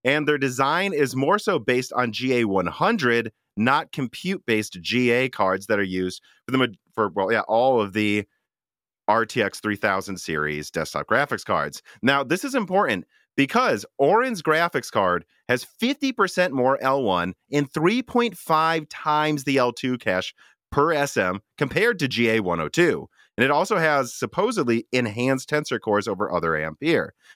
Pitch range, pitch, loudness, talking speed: 105-150 Hz, 125 Hz, -23 LUFS, 145 wpm